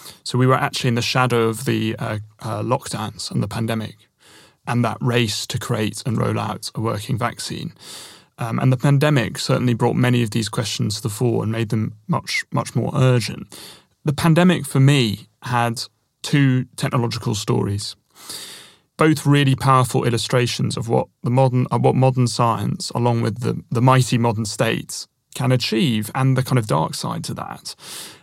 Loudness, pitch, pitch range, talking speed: -20 LUFS, 120 Hz, 115-130 Hz, 175 wpm